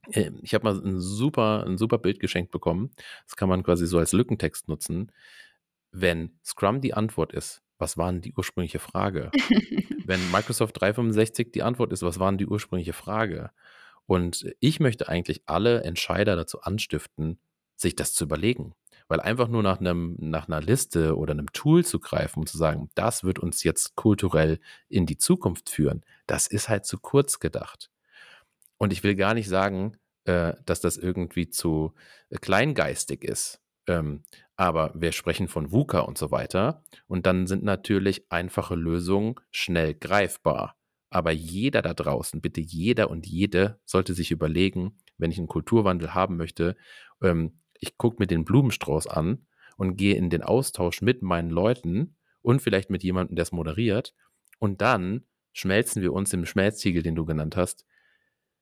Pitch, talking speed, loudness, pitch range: 95 Hz, 165 wpm, -26 LUFS, 85-105 Hz